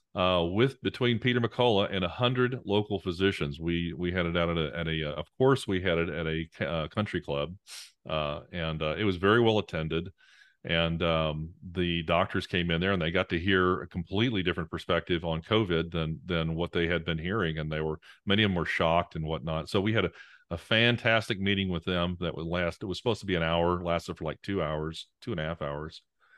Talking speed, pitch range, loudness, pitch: 230 wpm, 80-100 Hz, -29 LUFS, 85 Hz